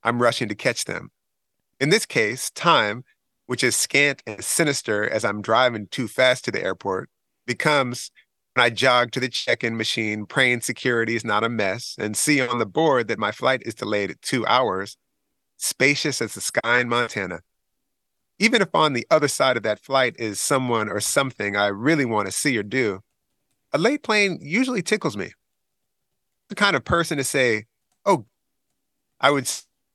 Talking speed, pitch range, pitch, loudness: 180 wpm, 105-135 Hz, 120 Hz, -21 LUFS